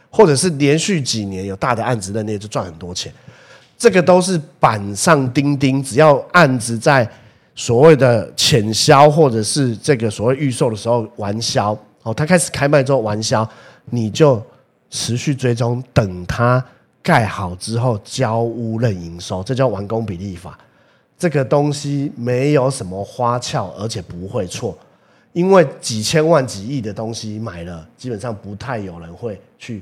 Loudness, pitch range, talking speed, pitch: -16 LUFS, 110-145 Hz, 245 characters per minute, 120 Hz